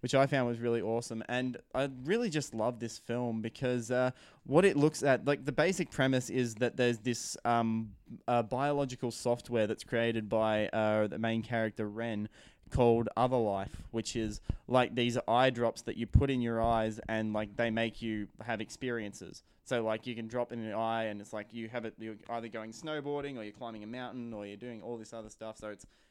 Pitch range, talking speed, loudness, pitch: 110-125 Hz, 215 wpm, -33 LUFS, 115 Hz